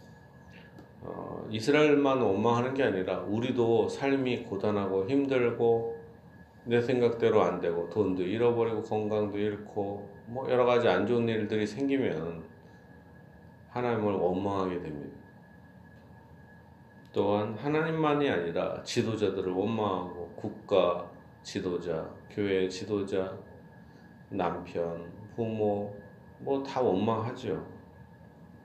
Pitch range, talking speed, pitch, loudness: 100-120 Hz, 230 characters per minute, 110 Hz, -30 LUFS